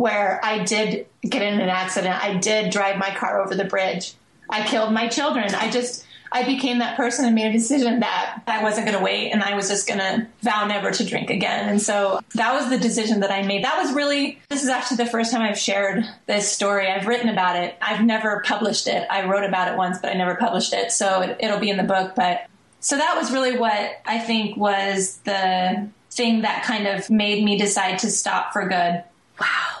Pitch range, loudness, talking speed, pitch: 195-235 Hz, -21 LUFS, 230 wpm, 215 Hz